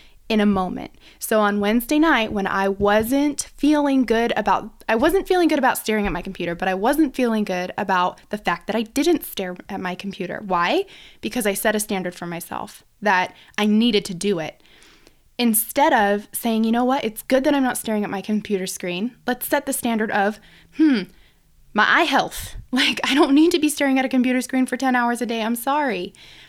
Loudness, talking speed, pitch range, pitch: -20 LUFS, 215 wpm, 200-260 Hz, 225 Hz